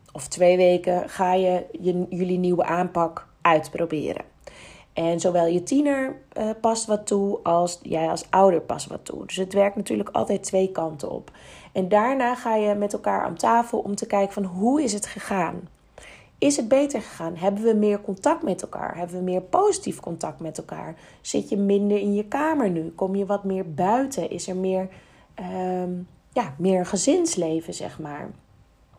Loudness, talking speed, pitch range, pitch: -24 LUFS, 180 wpm, 180-220 Hz, 195 Hz